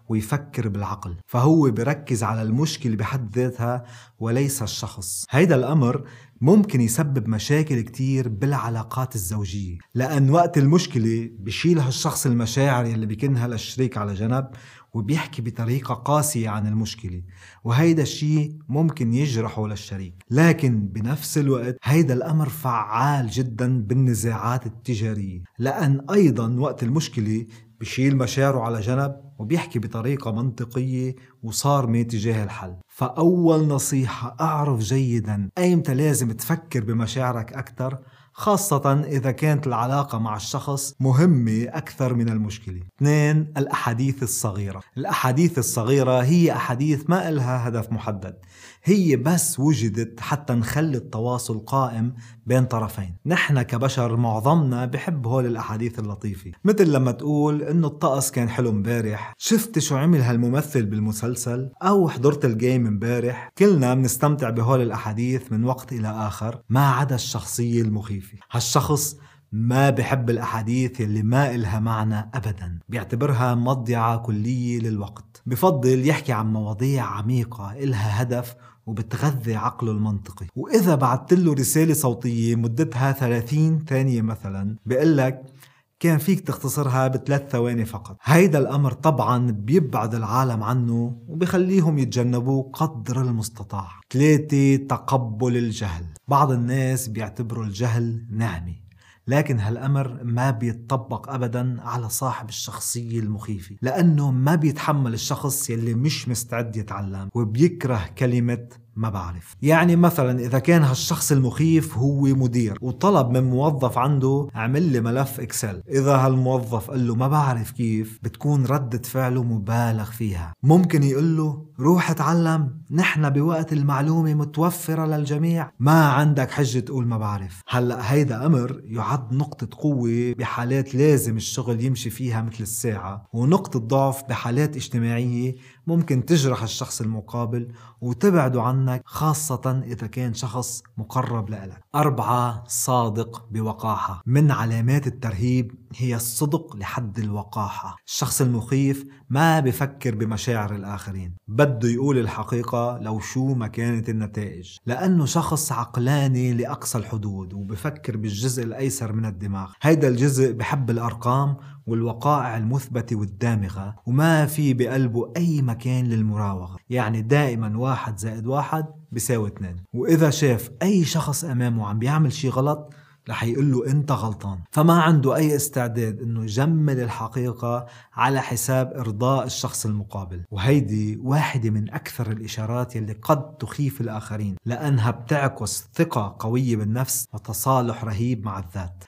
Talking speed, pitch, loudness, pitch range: 125 wpm, 125 Hz, -22 LUFS, 115-140 Hz